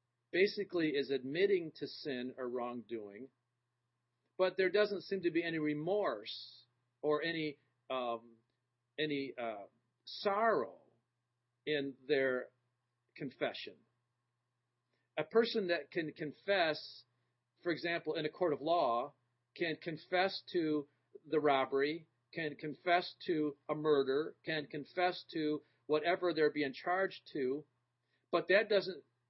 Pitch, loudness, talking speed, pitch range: 145 Hz, -36 LUFS, 115 wpm, 120-170 Hz